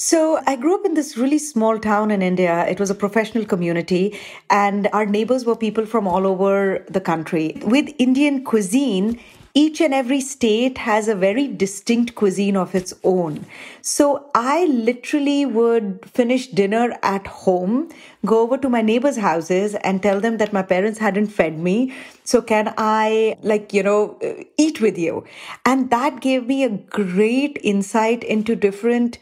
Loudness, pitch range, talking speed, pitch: -19 LUFS, 200-260 Hz, 170 wpm, 220 Hz